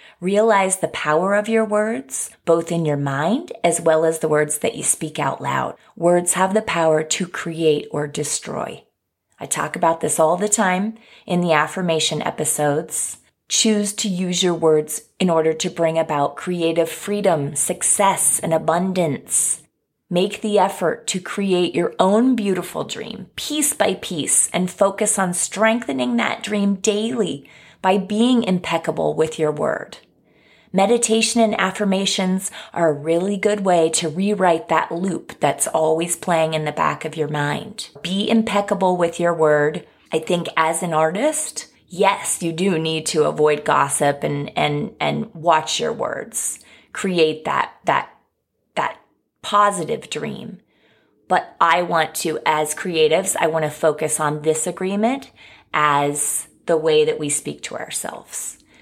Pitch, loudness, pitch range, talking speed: 170 Hz, -19 LUFS, 155-200 Hz, 155 wpm